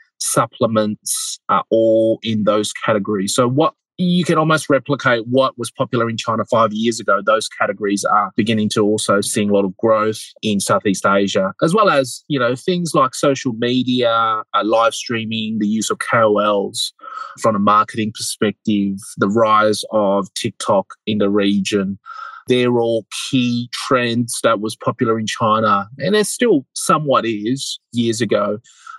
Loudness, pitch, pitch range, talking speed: -17 LUFS, 115 Hz, 105-130 Hz, 155 wpm